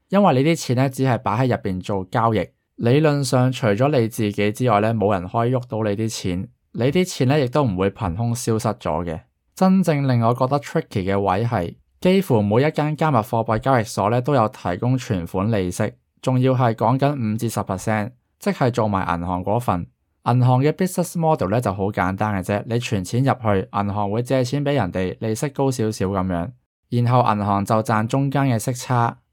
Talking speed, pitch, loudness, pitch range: 330 characters per minute, 115 Hz, -21 LUFS, 100-130 Hz